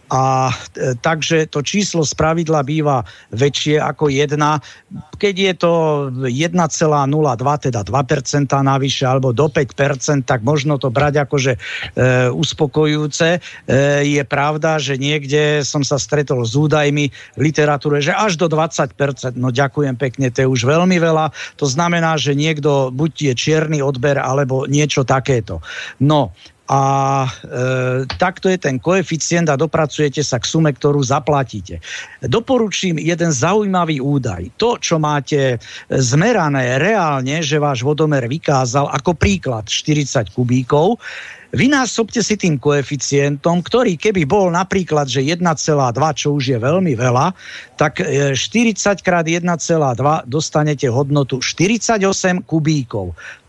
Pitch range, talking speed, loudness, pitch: 135-160 Hz, 130 wpm, -16 LUFS, 150 Hz